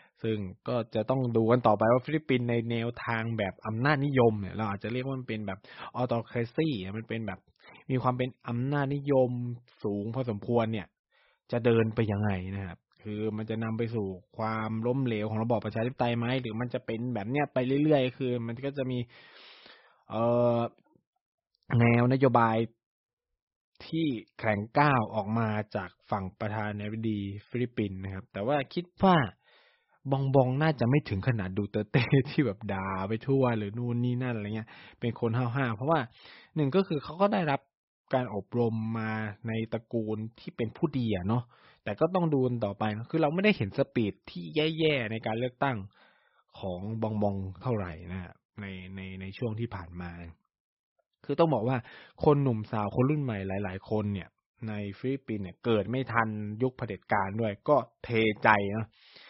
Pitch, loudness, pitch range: 115 Hz, -30 LUFS, 105-130 Hz